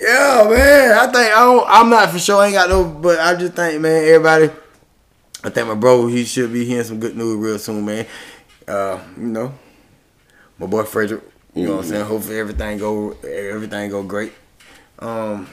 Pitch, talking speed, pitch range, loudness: 120 Hz, 200 wpm, 105-175 Hz, -14 LUFS